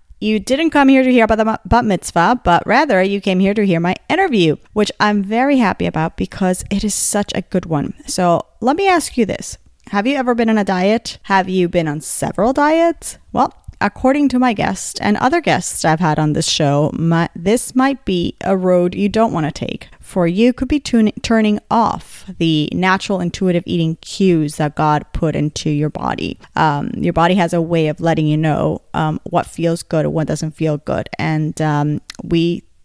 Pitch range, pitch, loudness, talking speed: 165-225 Hz, 185 Hz, -16 LUFS, 210 wpm